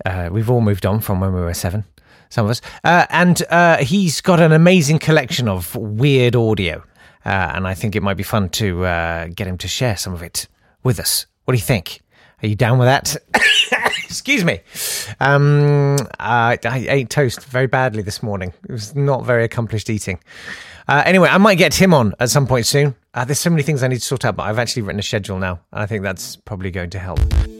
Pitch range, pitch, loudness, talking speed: 95-140 Hz, 115 Hz, -16 LUFS, 230 wpm